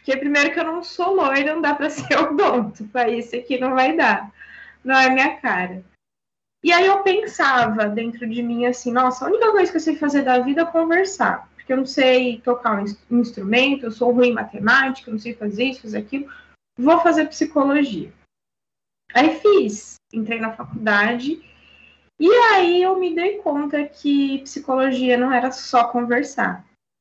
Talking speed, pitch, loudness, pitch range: 180 wpm, 265 Hz, -19 LUFS, 240-315 Hz